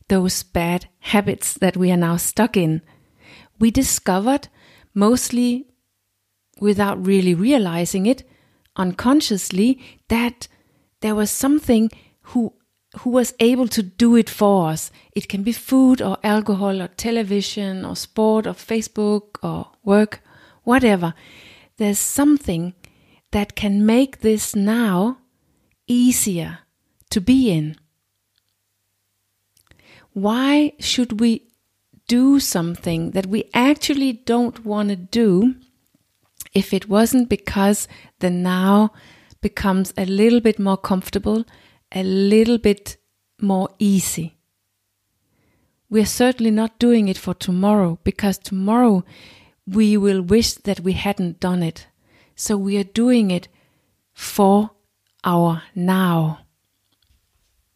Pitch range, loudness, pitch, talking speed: 175-225 Hz, -19 LUFS, 200 Hz, 115 wpm